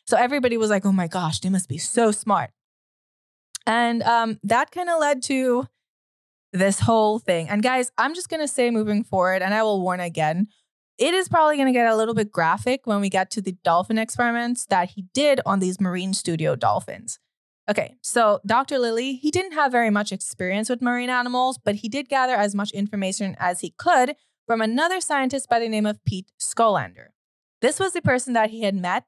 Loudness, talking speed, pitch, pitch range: -22 LUFS, 210 wpm, 225 Hz, 195-255 Hz